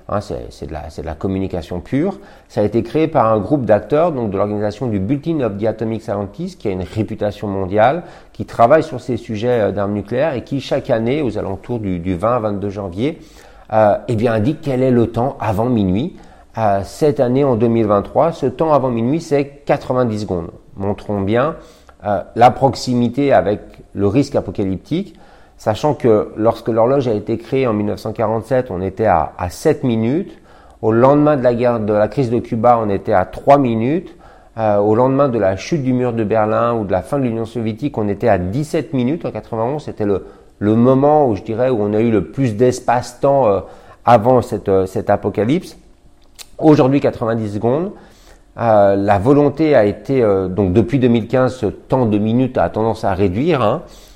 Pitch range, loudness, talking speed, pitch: 105-130 Hz, -16 LUFS, 195 wpm, 115 Hz